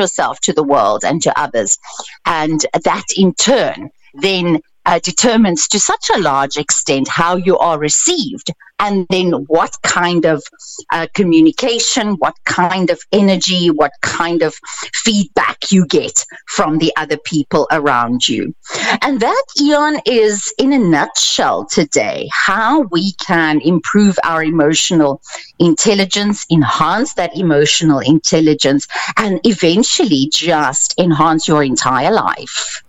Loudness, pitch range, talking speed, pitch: -13 LUFS, 155-210 Hz, 130 wpm, 175 Hz